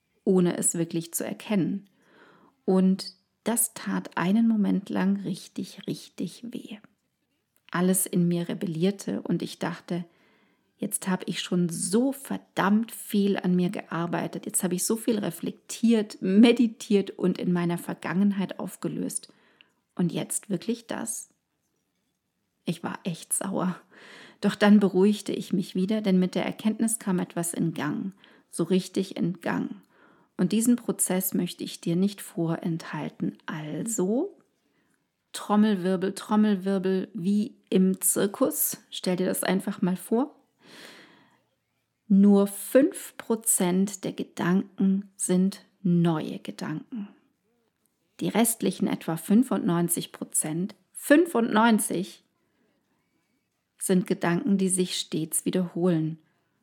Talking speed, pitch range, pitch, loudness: 115 wpm, 180-215 Hz, 195 Hz, -26 LUFS